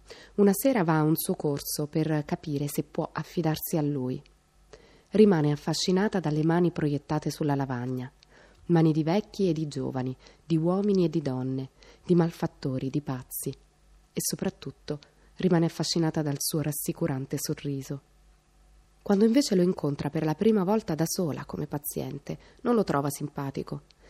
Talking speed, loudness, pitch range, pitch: 150 wpm, -28 LUFS, 145-175 Hz, 155 Hz